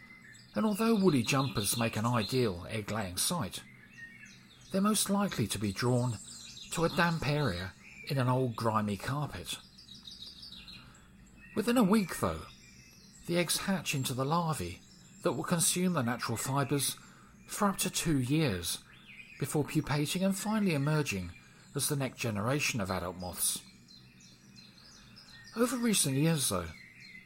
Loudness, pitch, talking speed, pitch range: -32 LUFS, 135 Hz, 135 wpm, 105-170 Hz